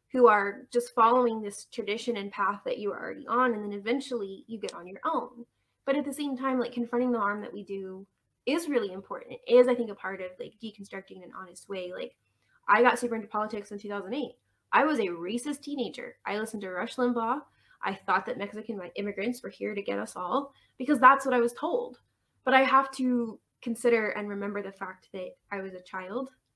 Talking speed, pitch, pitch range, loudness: 220 wpm, 230 Hz, 200-255 Hz, -29 LUFS